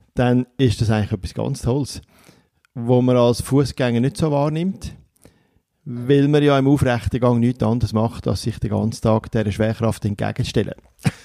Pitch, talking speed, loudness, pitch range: 120 Hz, 165 wpm, -20 LUFS, 110-130 Hz